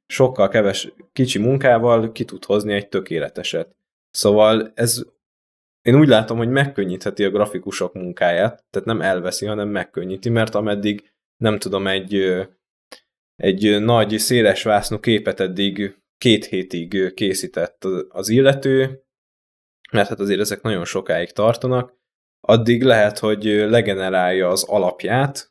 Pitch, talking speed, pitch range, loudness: 105 Hz, 125 wpm, 95-120 Hz, -19 LUFS